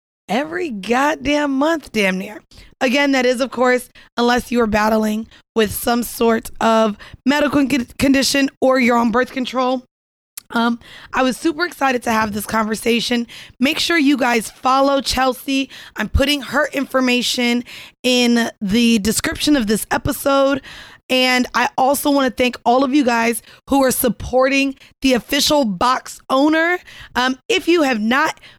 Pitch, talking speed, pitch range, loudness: 255 Hz, 150 wpm, 235-275 Hz, -17 LUFS